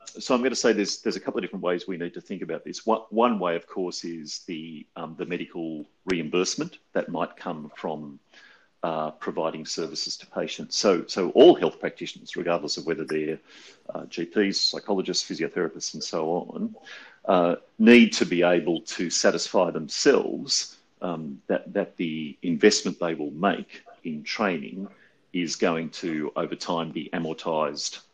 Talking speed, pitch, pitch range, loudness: 165 wpm, 85 Hz, 75-95 Hz, -25 LUFS